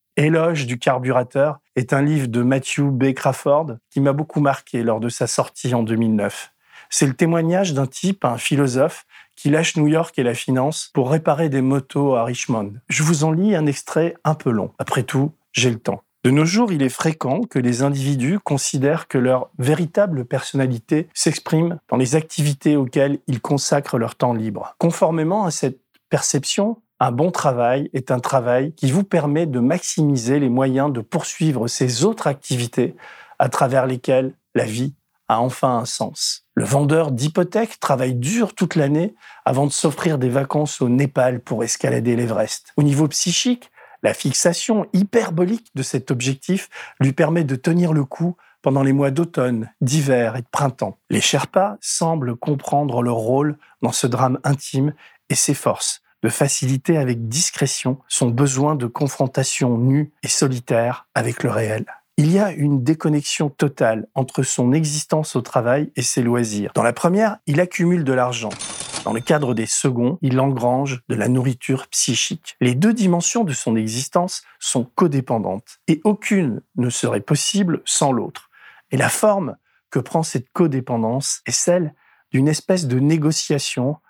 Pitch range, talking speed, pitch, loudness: 130-160 Hz, 170 wpm, 140 Hz, -19 LUFS